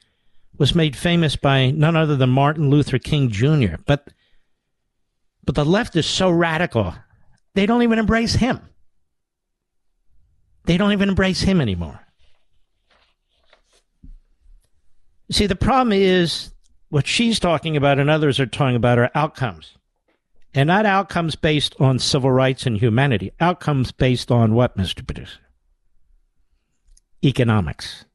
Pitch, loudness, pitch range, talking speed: 140 Hz, -19 LUFS, 115-170 Hz, 130 wpm